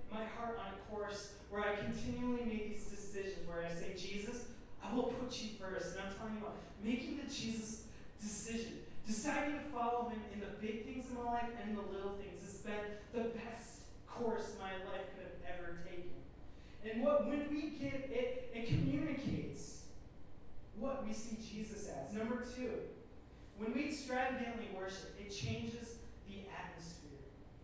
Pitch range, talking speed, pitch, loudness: 195-240 Hz, 170 wpm, 220 Hz, -43 LUFS